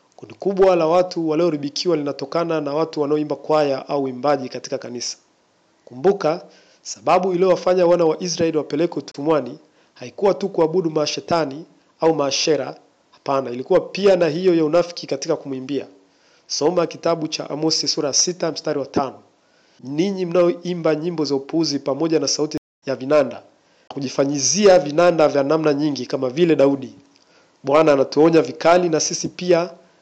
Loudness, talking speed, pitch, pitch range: -19 LUFS, 140 wpm, 155 Hz, 140-170 Hz